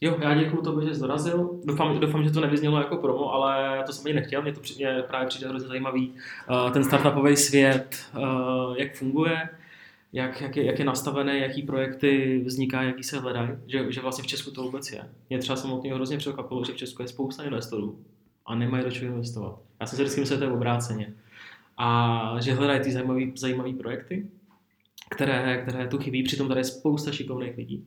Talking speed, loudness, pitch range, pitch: 200 wpm, -27 LUFS, 130-140 Hz, 130 Hz